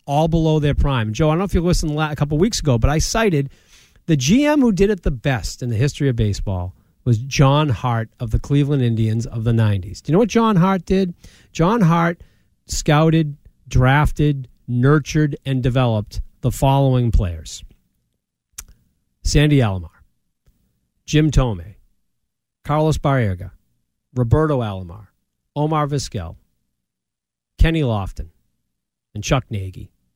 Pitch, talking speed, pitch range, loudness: 130 Hz, 145 wpm, 105-155 Hz, -18 LUFS